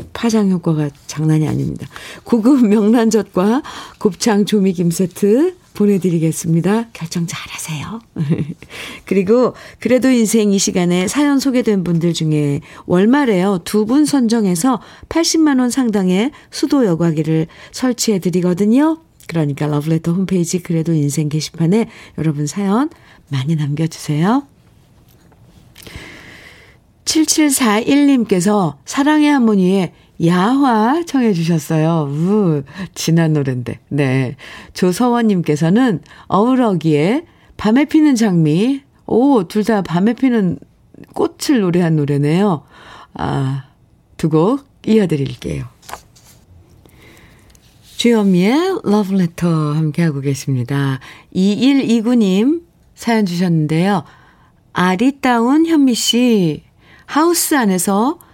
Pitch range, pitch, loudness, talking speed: 160-240 Hz, 195 Hz, -15 LUFS, 235 characters per minute